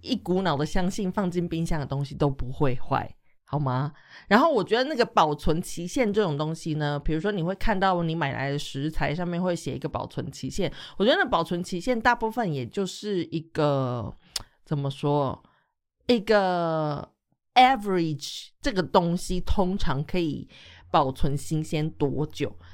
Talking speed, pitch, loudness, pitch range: 265 characters per minute, 160 Hz, -26 LUFS, 145-185 Hz